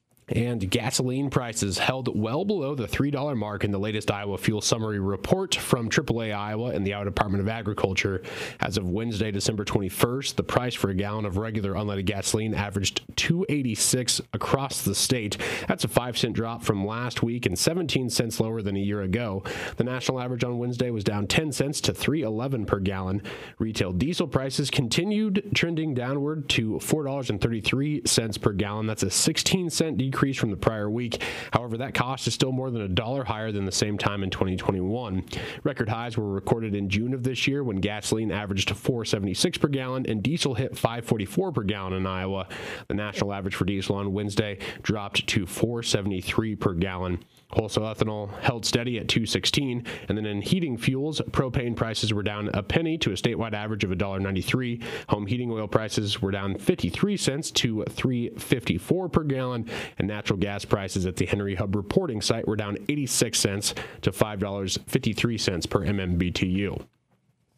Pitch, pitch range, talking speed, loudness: 115 Hz, 100-130 Hz, 175 wpm, -27 LUFS